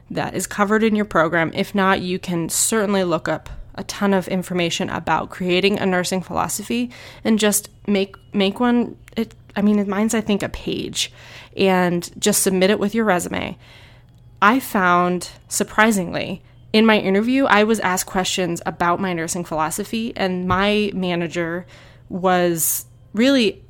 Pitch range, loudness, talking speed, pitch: 175-210 Hz, -19 LUFS, 155 wpm, 190 Hz